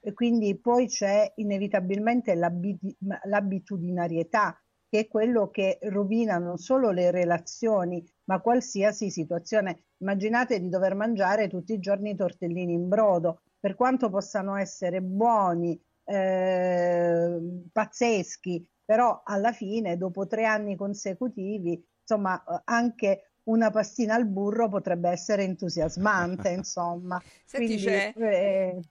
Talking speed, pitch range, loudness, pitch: 115 wpm, 180-220 Hz, -27 LUFS, 200 Hz